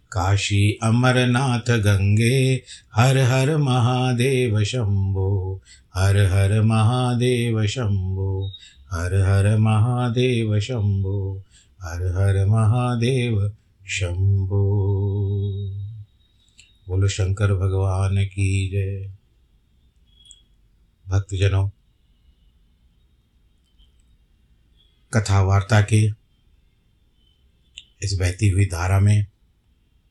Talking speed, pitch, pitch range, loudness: 65 wpm, 100 Hz, 95-110 Hz, -21 LUFS